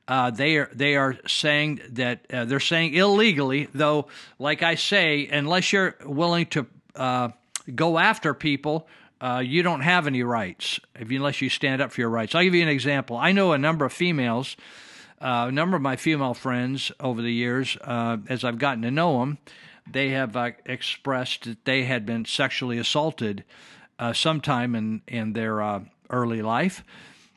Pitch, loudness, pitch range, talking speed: 135 Hz, -24 LUFS, 120-155 Hz, 185 wpm